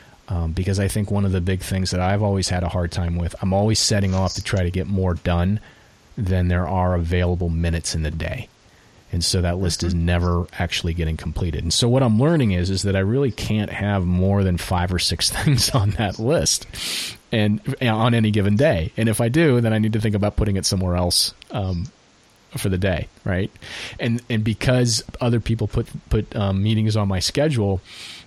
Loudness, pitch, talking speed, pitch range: -21 LUFS, 95 Hz, 215 wpm, 90-110 Hz